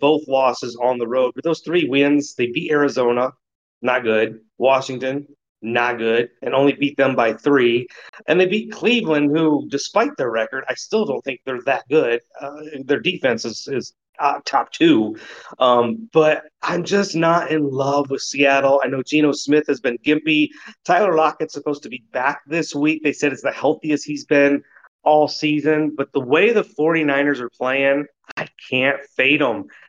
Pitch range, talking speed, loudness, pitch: 130-150 Hz, 180 wpm, -19 LUFS, 140 Hz